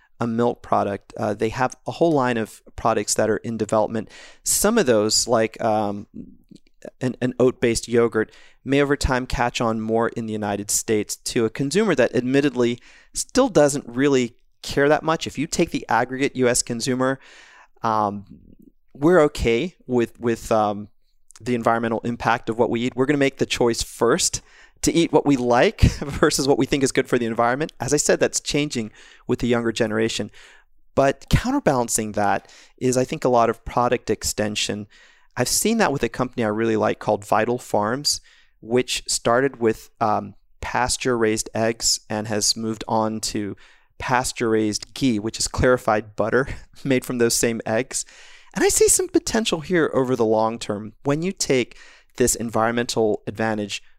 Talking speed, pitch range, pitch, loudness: 175 wpm, 110-130 Hz, 120 Hz, -21 LUFS